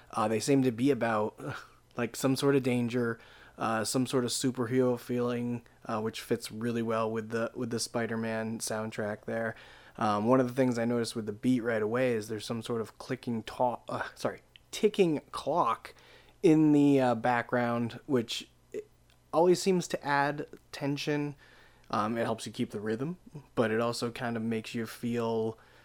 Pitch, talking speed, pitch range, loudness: 120 Hz, 180 wpm, 115-135 Hz, -31 LUFS